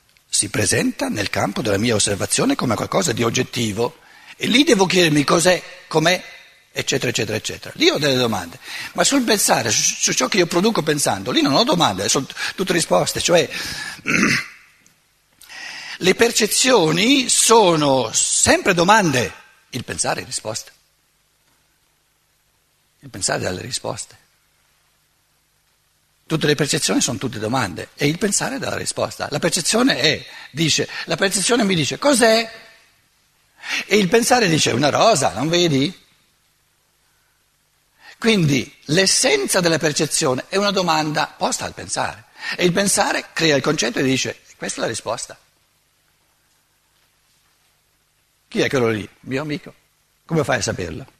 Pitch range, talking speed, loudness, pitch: 145-215 Hz, 140 wpm, -18 LUFS, 170 Hz